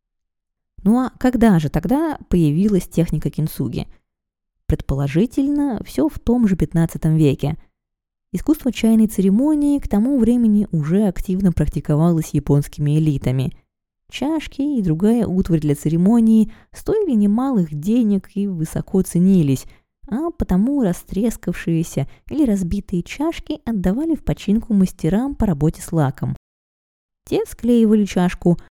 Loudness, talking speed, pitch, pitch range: -19 LUFS, 115 wpm, 195 Hz, 160-235 Hz